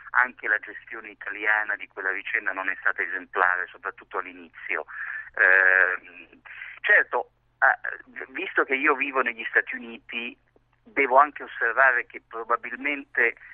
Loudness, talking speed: -24 LUFS, 120 wpm